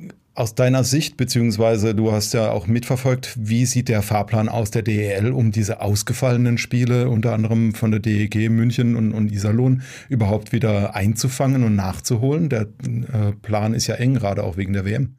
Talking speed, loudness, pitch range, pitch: 180 wpm, -20 LUFS, 110-125 Hz, 115 Hz